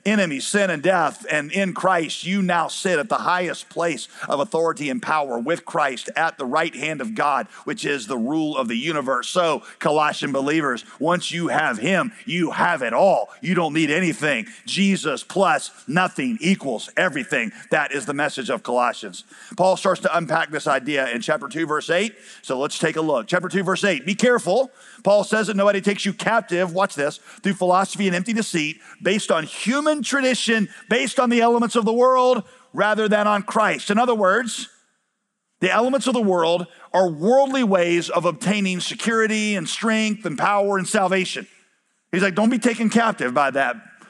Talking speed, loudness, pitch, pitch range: 190 wpm, -21 LUFS, 195 Hz, 170-225 Hz